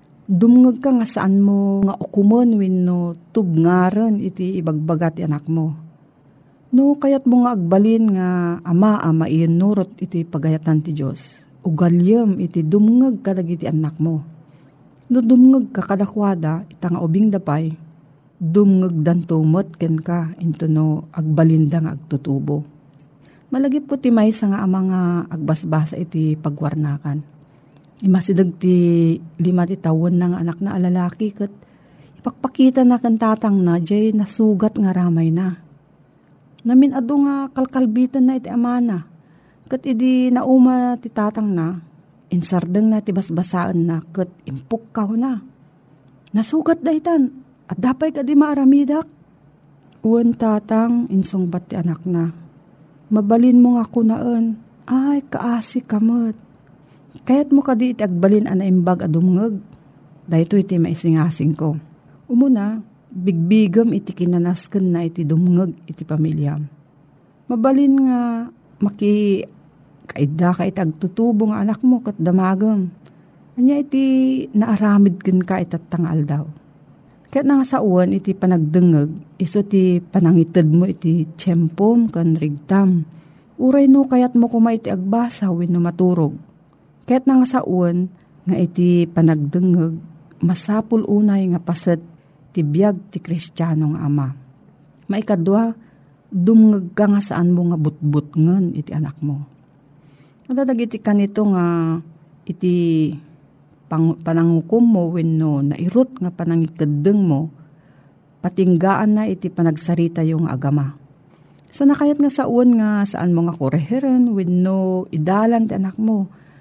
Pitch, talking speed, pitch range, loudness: 180 Hz, 130 wpm, 160-220 Hz, -17 LUFS